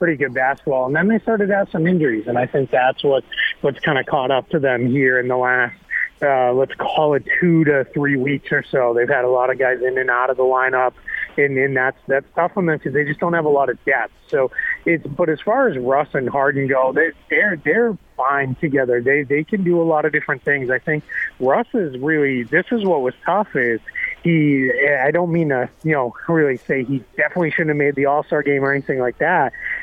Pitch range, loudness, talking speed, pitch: 130-165 Hz, -18 LUFS, 245 wpm, 145 Hz